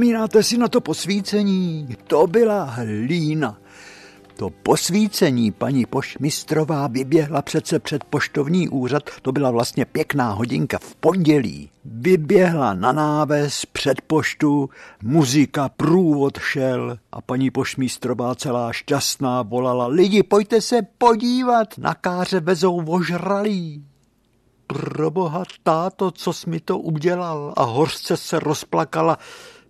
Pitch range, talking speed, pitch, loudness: 130-185 Hz, 115 wpm, 155 Hz, -20 LUFS